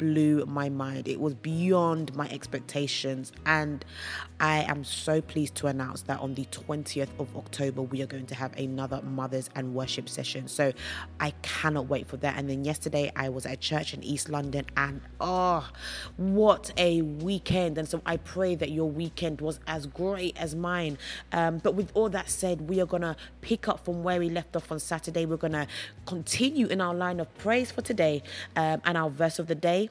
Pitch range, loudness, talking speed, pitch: 140-175 Hz, -30 LUFS, 205 wpm, 155 Hz